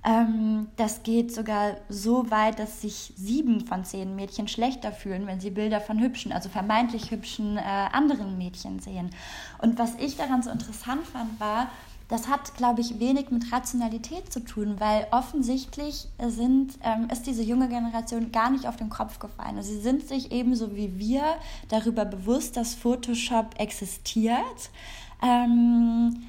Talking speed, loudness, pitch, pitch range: 160 wpm, -27 LUFS, 230 Hz, 215-245 Hz